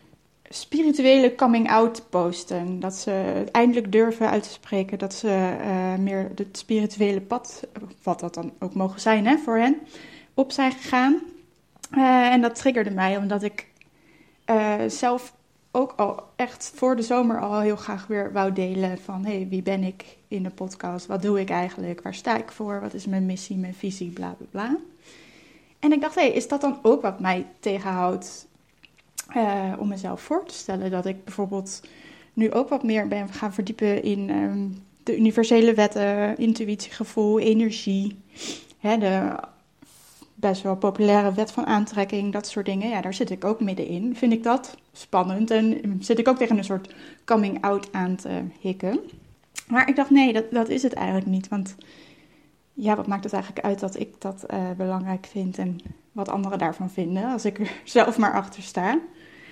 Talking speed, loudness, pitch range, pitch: 180 wpm, -24 LUFS, 190-240 Hz, 210 Hz